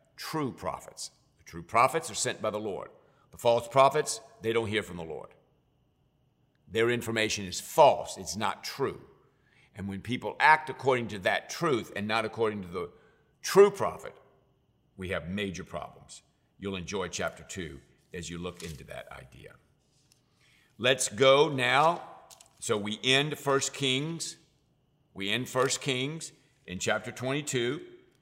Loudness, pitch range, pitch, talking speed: -28 LUFS, 100-140 Hz, 120 Hz, 150 wpm